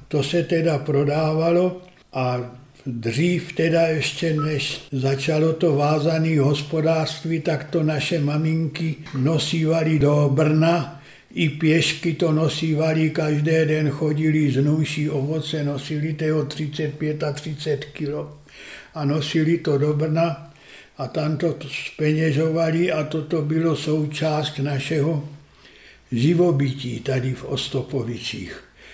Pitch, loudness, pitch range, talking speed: 155 Hz, -21 LUFS, 145-160 Hz, 110 wpm